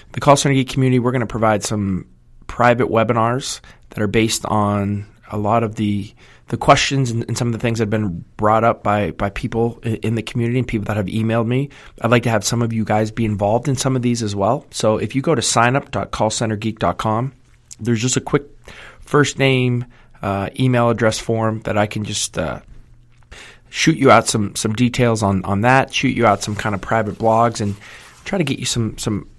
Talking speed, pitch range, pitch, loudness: 215 wpm, 105-125 Hz, 115 Hz, -18 LUFS